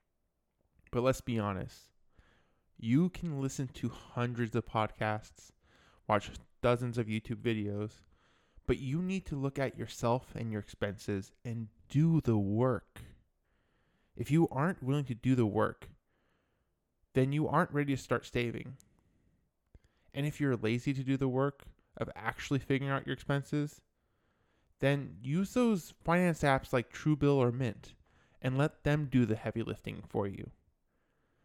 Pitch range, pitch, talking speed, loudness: 110-140 Hz, 125 Hz, 145 wpm, -34 LUFS